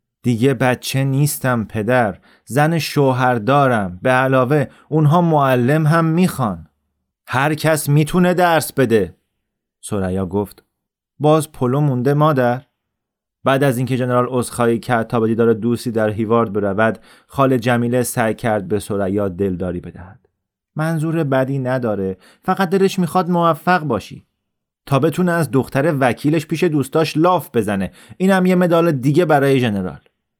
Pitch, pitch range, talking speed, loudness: 130 Hz, 115-155 Hz, 130 wpm, -17 LUFS